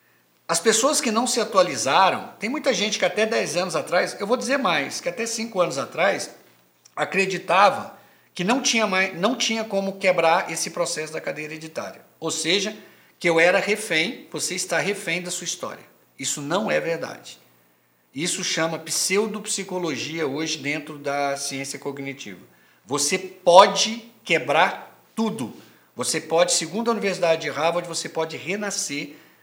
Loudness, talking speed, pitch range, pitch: -22 LUFS, 155 wpm, 160-210 Hz, 180 Hz